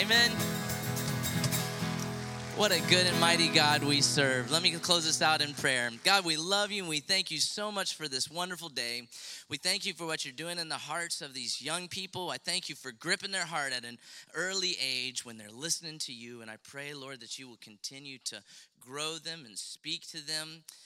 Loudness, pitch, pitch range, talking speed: -30 LUFS, 155 Hz, 130-175 Hz, 215 wpm